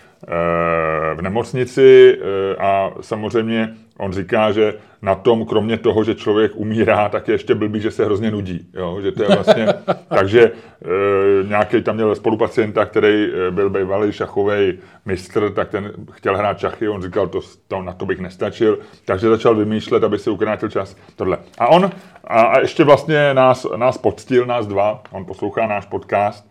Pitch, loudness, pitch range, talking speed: 105 Hz, -17 LUFS, 100-115 Hz, 165 wpm